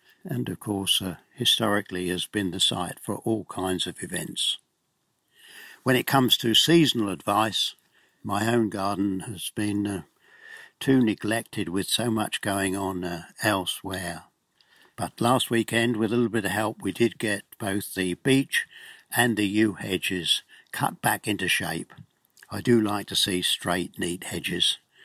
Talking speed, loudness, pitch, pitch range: 160 wpm, -25 LUFS, 105 Hz, 95-115 Hz